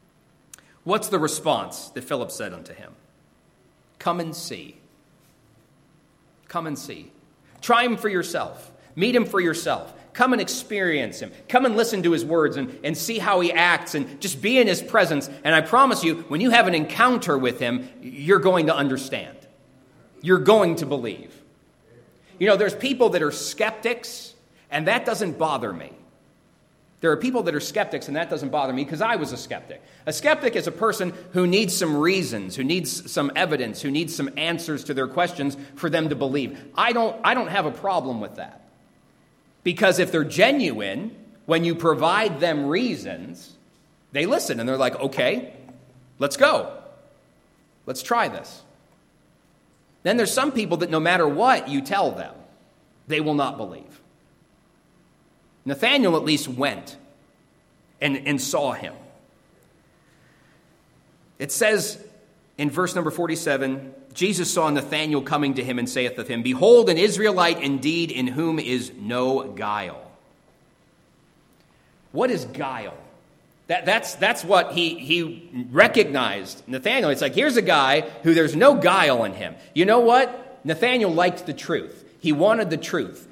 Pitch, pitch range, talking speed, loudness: 165 Hz, 145-205 Hz, 160 wpm, -22 LUFS